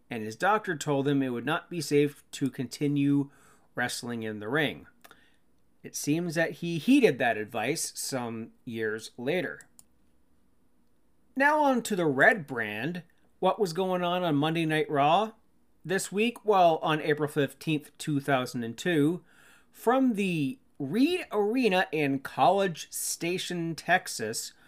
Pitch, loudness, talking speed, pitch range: 155 Hz, -28 LUFS, 135 wpm, 140-185 Hz